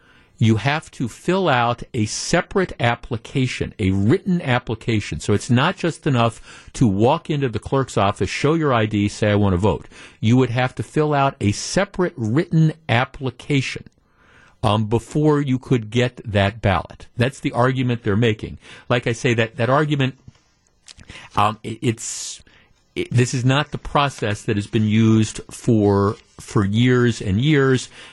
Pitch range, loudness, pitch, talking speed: 105-135 Hz, -20 LUFS, 120 Hz, 160 wpm